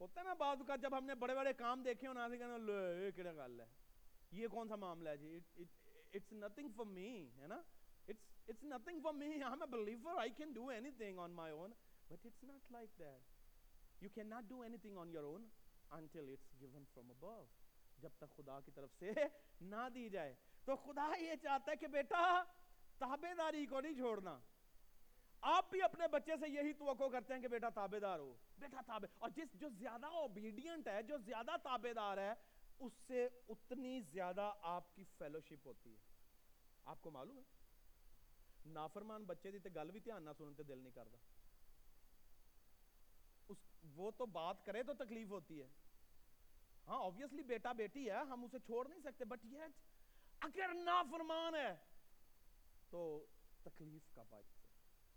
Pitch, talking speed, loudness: 220 Hz, 175 wpm, -47 LUFS